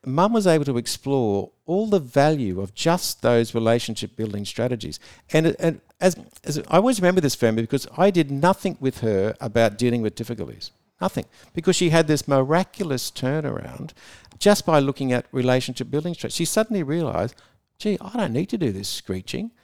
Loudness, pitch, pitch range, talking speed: -22 LUFS, 140 Hz, 115-175 Hz, 175 wpm